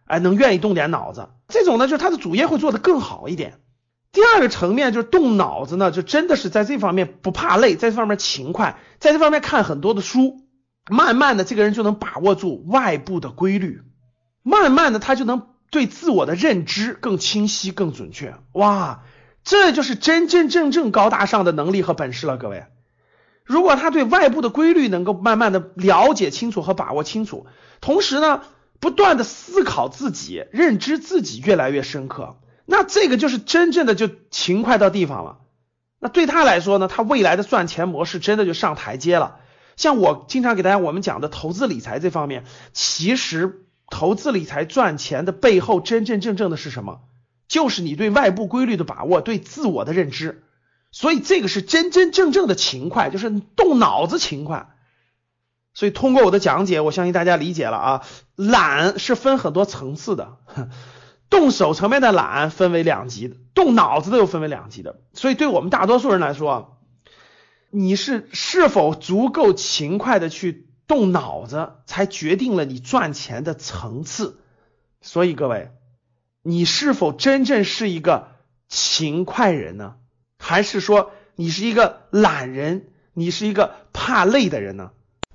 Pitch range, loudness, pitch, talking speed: 155-250 Hz, -18 LUFS, 195 Hz, 270 characters per minute